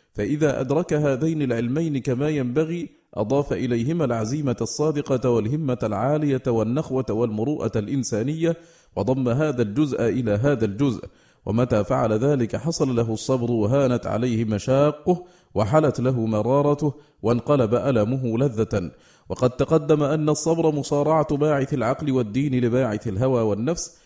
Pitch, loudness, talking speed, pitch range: 130 Hz, -22 LUFS, 115 wpm, 115-150 Hz